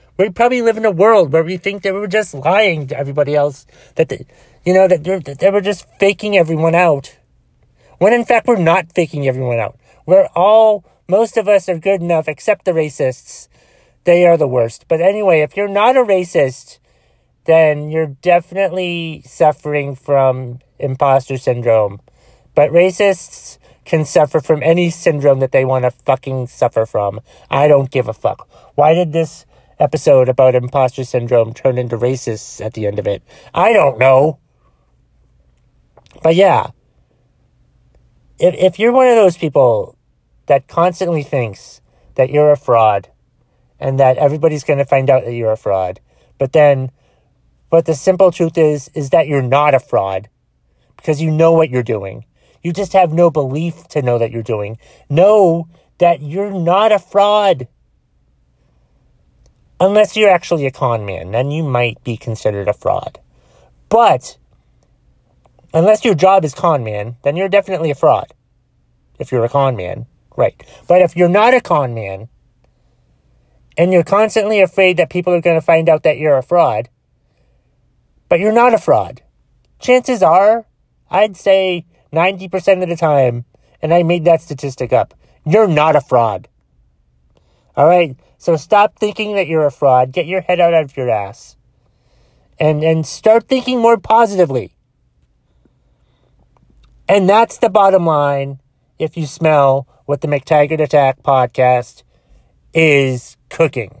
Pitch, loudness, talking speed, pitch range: 155 Hz, -14 LUFS, 160 wpm, 130-185 Hz